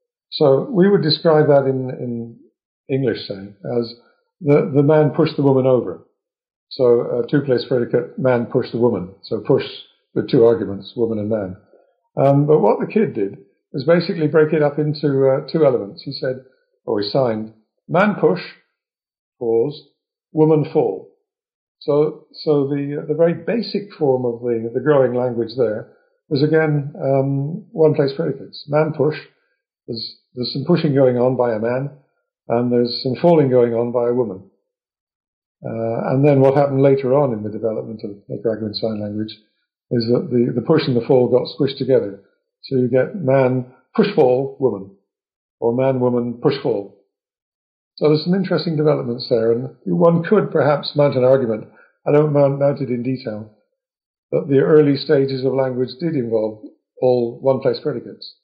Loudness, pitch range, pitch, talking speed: -18 LUFS, 120-155 Hz, 135 Hz, 165 wpm